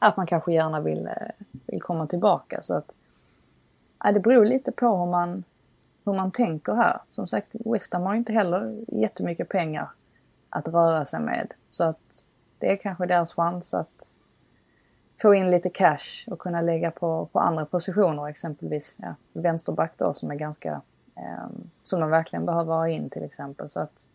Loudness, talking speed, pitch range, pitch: -25 LUFS, 175 wpm, 160-195 Hz, 175 Hz